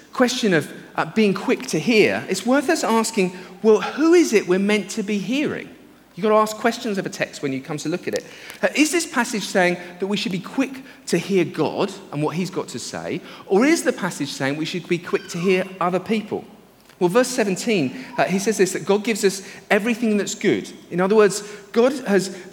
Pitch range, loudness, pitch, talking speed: 185-230 Hz, -21 LUFS, 205 Hz, 230 wpm